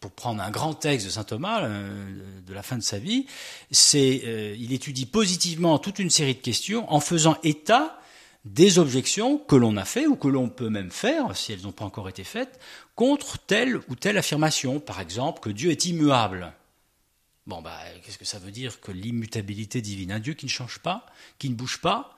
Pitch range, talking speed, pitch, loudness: 105-160 Hz, 210 wpm, 130 Hz, -24 LUFS